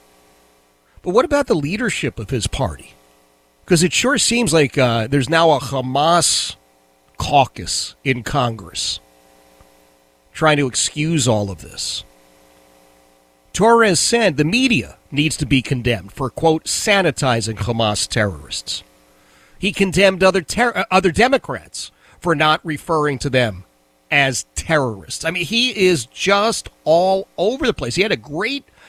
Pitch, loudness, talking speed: 130 Hz, -17 LUFS, 135 wpm